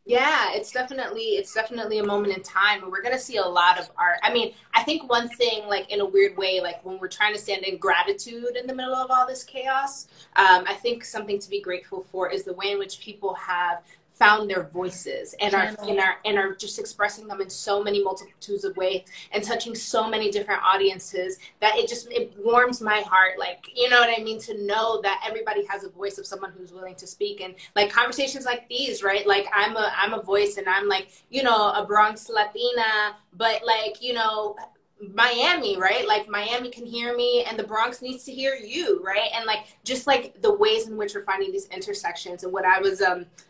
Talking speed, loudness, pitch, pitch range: 225 wpm, -23 LUFS, 210 Hz, 195-245 Hz